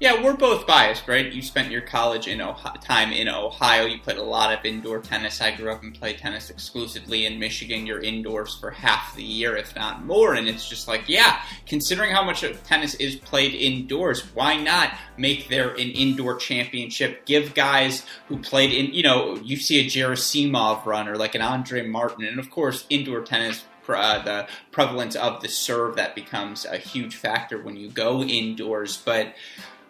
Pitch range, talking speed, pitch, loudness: 110-135 Hz, 195 wpm, 125 Hz, -22 LUFS